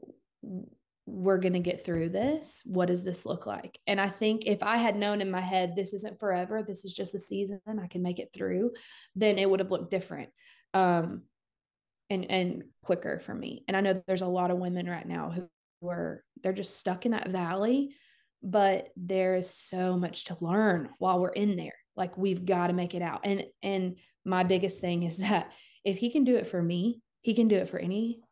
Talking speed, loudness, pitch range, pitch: 220 wpm, -30 LUFS, 180-210 Hz, 190 Hz